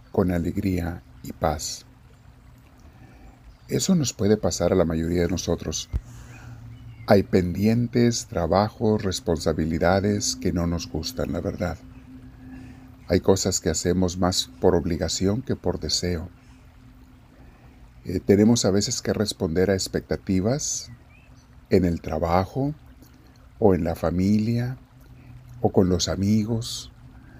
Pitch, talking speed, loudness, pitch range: 95 Hz, 115 wpm, -24 LUFS, 85-120 Hz